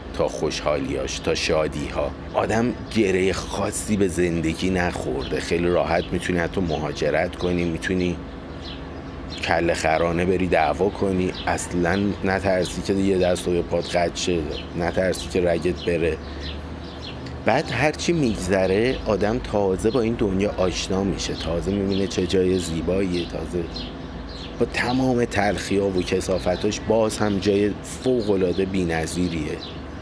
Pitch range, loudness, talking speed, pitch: 85-95 Hz, -23 LUFS, 125 wpm, 90 Hz